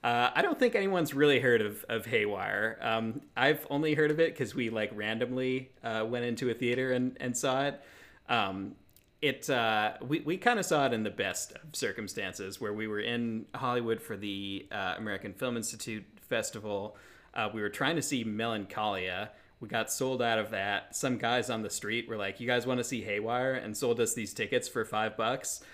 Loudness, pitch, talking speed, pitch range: -32 LUFS, 120 Hz, 205 wpm, 110-130 Hz